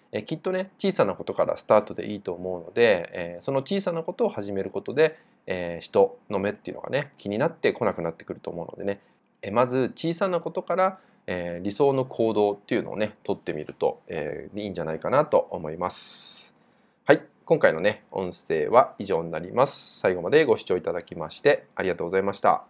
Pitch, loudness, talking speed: 170 Hz, -26 LUFS, 440 characters per minute